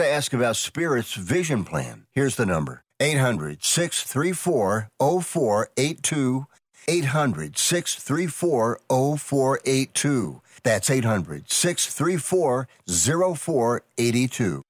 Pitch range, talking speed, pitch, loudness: 120-160 Hz, 55 wpm, 135 Hz, -23 LUFS